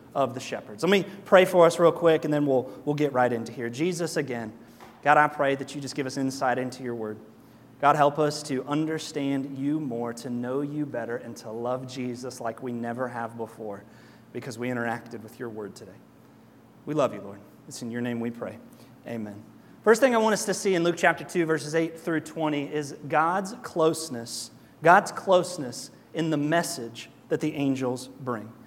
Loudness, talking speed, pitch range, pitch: -26 LUFS, 205 wpm, 120-155 Hz, 135 Hz